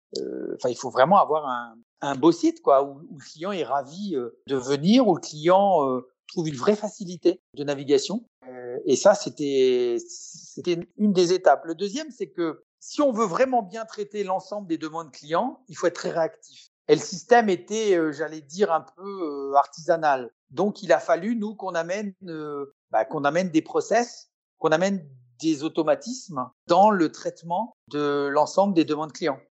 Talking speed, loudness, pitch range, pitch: 190 wpm, -24 LUFS, 145-205 Hz, 170 Hz